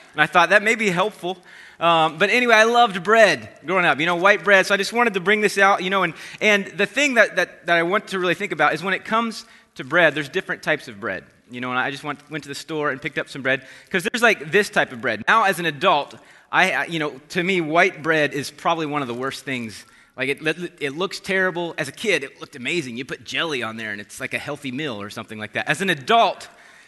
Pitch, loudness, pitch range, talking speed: 170 Hz, -20 LUFS, 145-200 Hz, 270 wpm